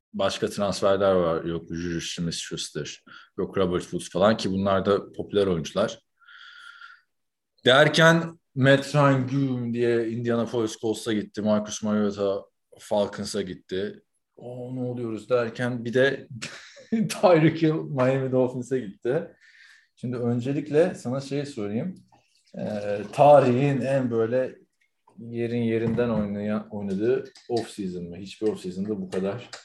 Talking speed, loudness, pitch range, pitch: 120 wpm, -25 LUFS, 105-135 Hz, 120 Hz